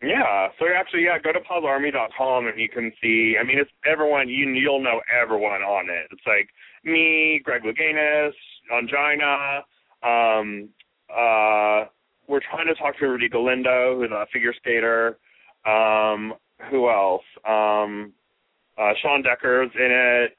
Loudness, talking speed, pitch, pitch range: -21 LUFS, 145 wpm, 125 Hz, 110-145 Hz